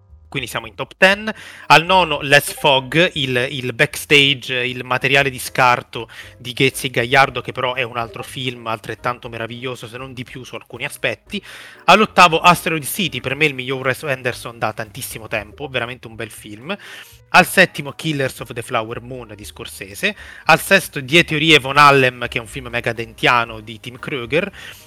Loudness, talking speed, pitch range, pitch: -16 LUFS, 175 wpm, 120-145 Hz, 130 Hz